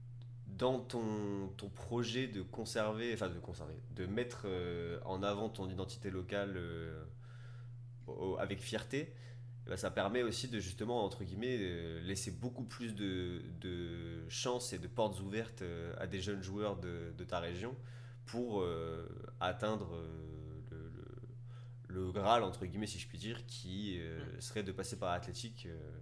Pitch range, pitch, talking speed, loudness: 95-120 Hz, 110 Hz, 140 wpm, -41 LUFS